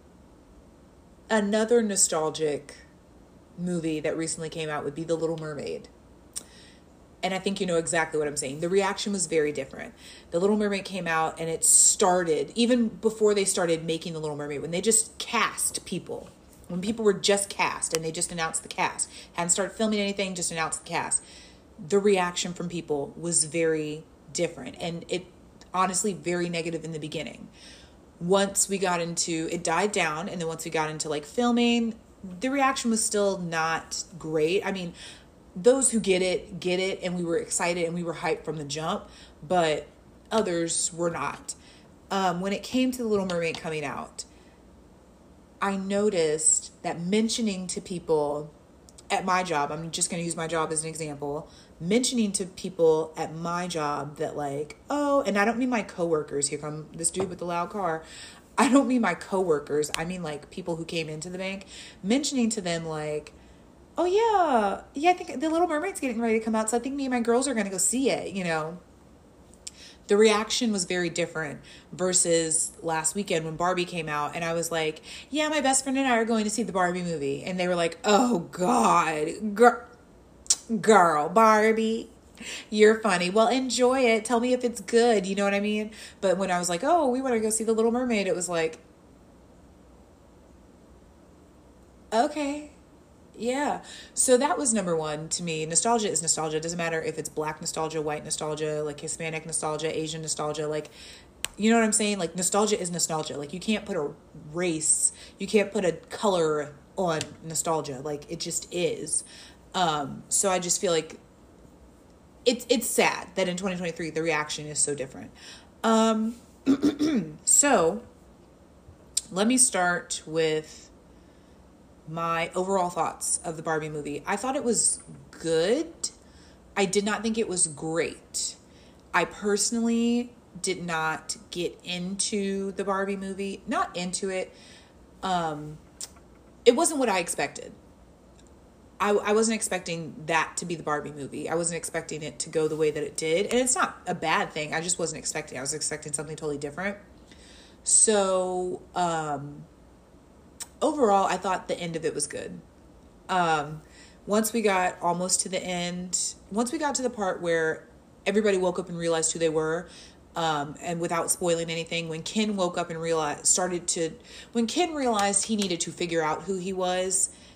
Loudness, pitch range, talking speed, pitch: -26 LUFS, 160-210 Hz, 180 wpm, 180 Hz